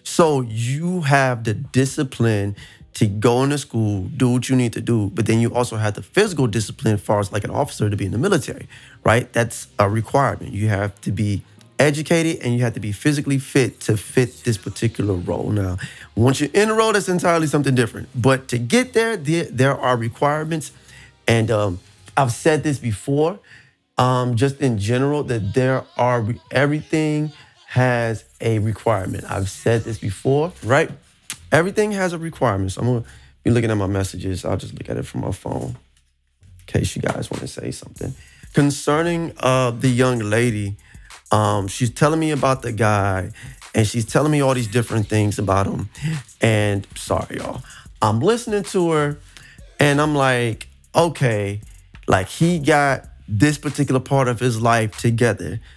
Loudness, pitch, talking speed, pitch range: -20 LUFS, 120 Hz, 180 wpm, 105-140 Hz